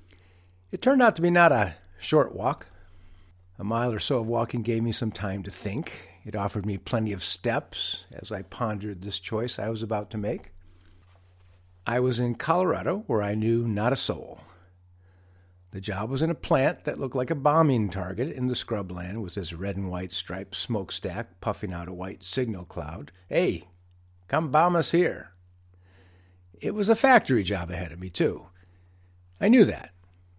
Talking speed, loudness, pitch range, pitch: 180 wpm, -27 LUFS, 90-115 Hz, 95 Hz